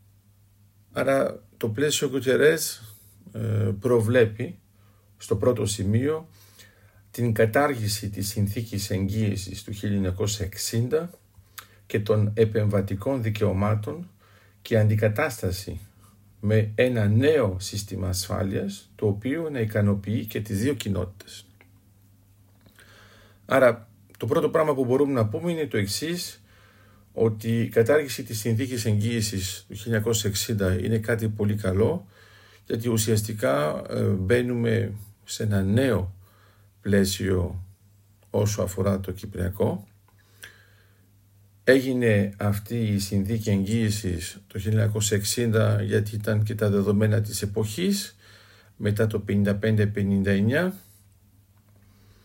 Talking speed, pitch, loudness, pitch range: 100 wpm, 105 Hz, -25 LUFS, 100-115 Hz